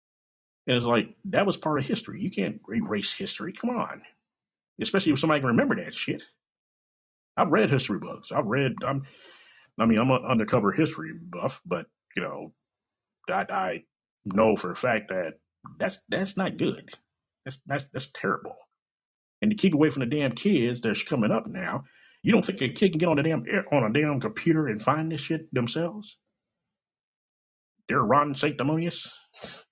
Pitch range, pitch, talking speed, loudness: 135-170 Hz, 155 Hz, 175 wpm, -27 LUFS